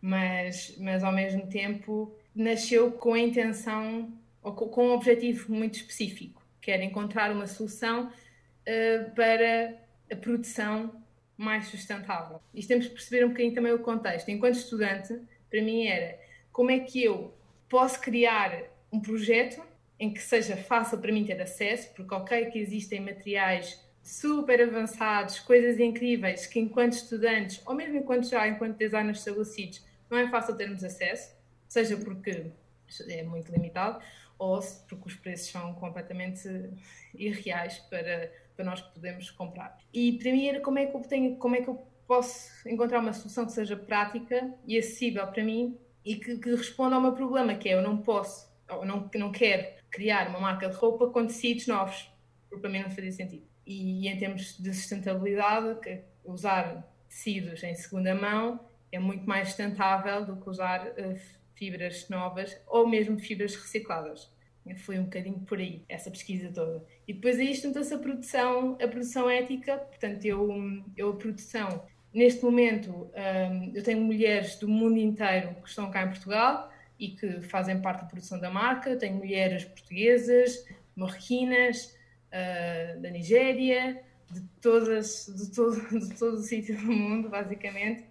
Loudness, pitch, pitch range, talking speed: -29 LUFS, 215 Hz, 190-235 Hz, 165 wpm